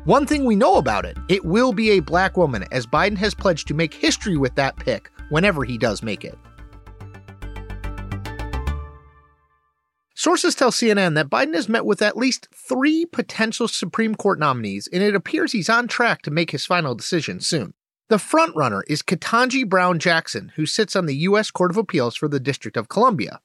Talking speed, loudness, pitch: 185 wpm, -20 LUFS, 175 Hz